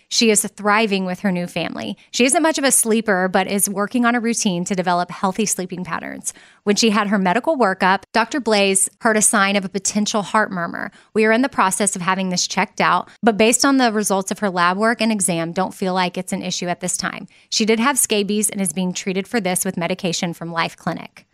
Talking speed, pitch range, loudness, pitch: 240 wpm, 185-225 Hz, -18 LUFS, 205 Hz